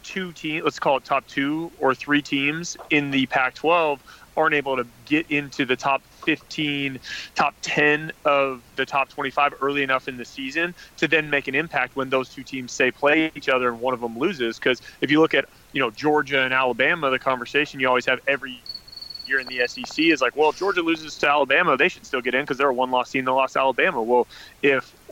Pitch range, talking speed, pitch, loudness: 130-150 Hz, 225 wpm, 140 Hz, -22 LUFS